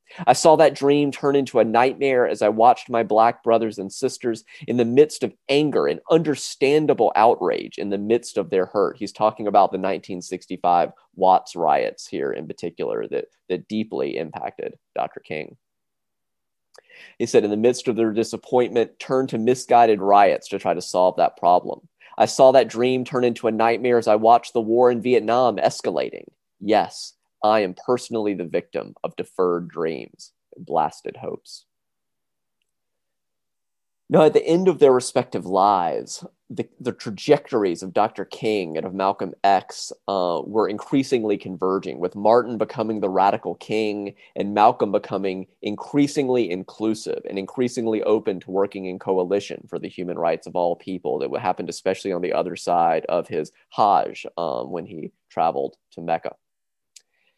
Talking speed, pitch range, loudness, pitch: 160 wpm, 95-125 Hz, -21 LUFS, 110 Hz